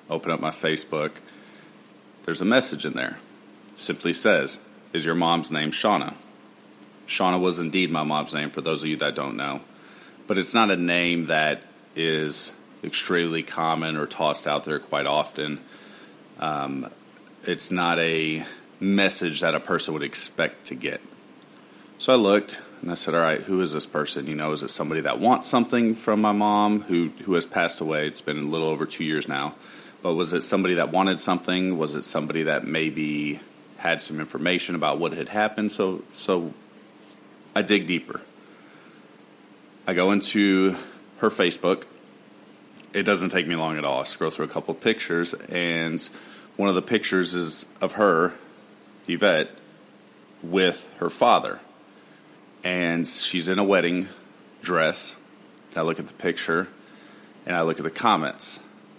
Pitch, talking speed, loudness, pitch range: 85 Hz, 170 wpm, -24 LUFS, 80-100 Hz